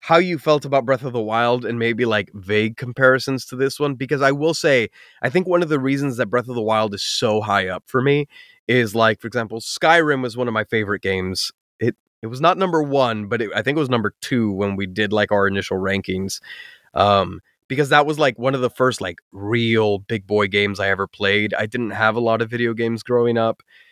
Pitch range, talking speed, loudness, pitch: 105-135 Hz, 240 wpm, -20 LUFS, 115 Hz